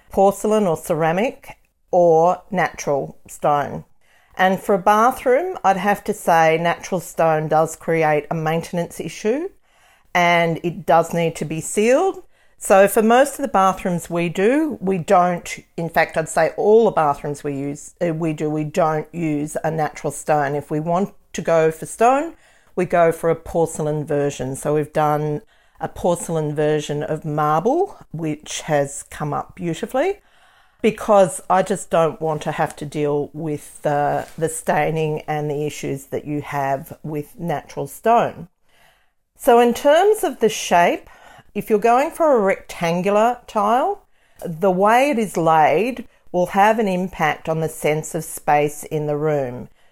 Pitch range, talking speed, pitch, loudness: 155-210 Hz, 160 wpm, 170 Hz, -19 LUFS